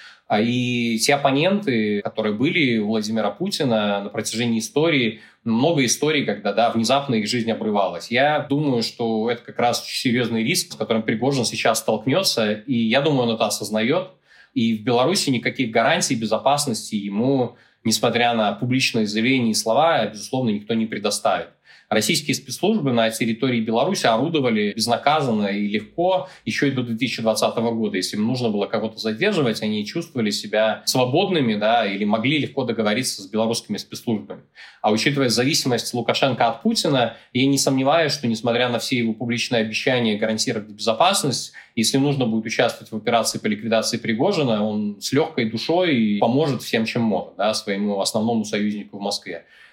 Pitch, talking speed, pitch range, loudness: 115 Hz, 155 wpm, 110-130 Hz, -21 LUFS